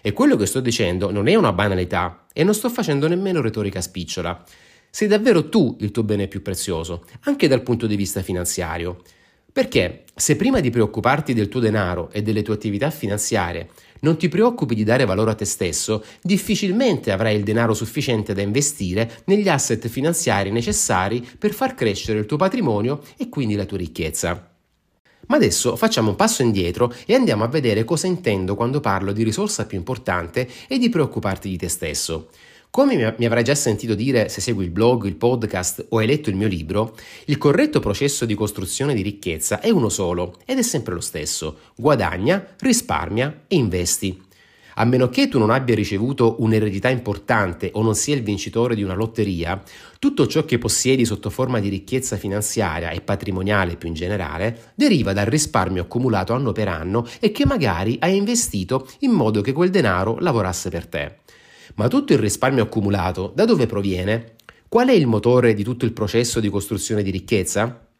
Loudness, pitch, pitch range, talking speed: -20 LUFS, 110 Hz, 100-130 Hz, 180 wpm